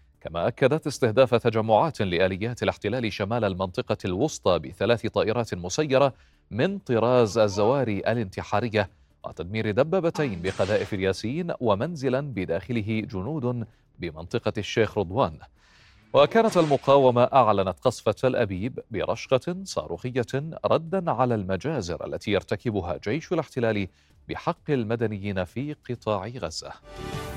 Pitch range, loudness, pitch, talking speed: 100-130 Hz, -25 LUFS, 115 Hz, 100 wpm